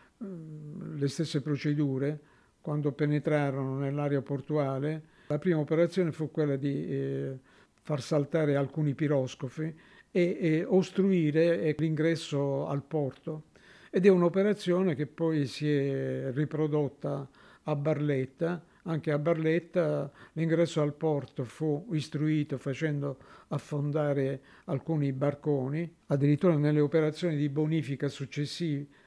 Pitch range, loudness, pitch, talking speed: 140-160 Hz, -30 LUFS, 150 Hz, 105 wpm